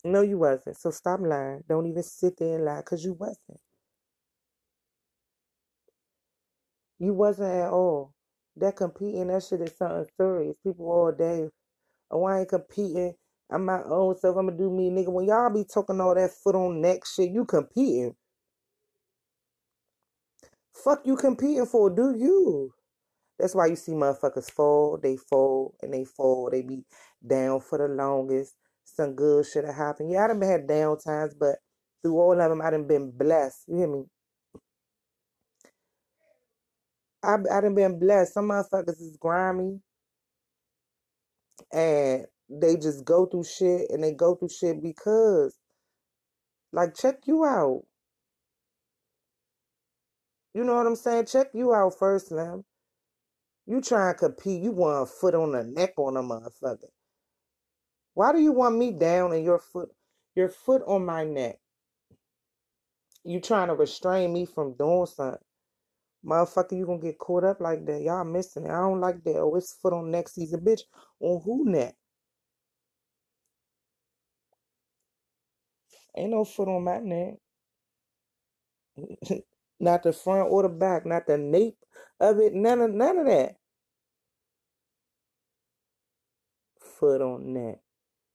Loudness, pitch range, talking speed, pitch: -26 LUFS, 160-205 Hz, 150 wpm, 180 Hz